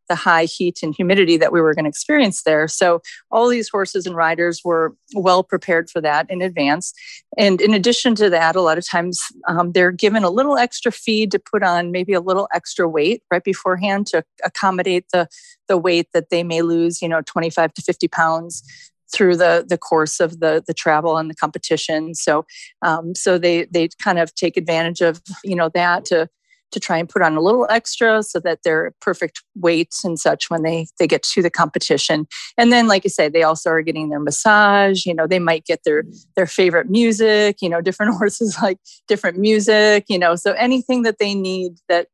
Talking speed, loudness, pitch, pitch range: 210 wpm, -17 LUFS, 180 Hz, 165-205 Hz